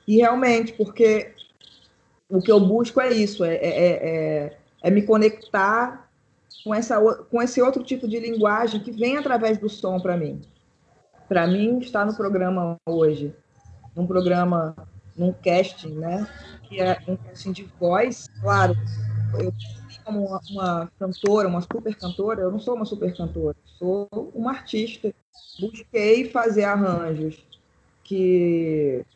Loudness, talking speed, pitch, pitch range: -23 LUFS, 140 wpm, 190 Hz, 165-220 Hz